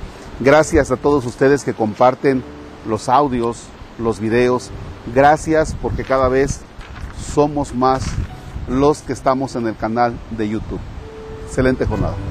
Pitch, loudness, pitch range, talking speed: 120 Hz, -17 LUFS, 105-135 Hz, 125 wpm